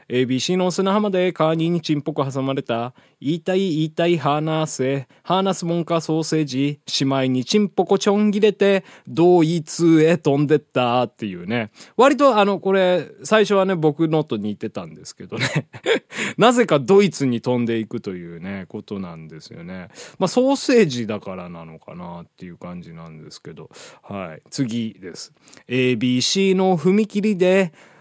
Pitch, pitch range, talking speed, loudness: 155 Hz, 120-190 Hz, 325 characters per minute, -19 LUFS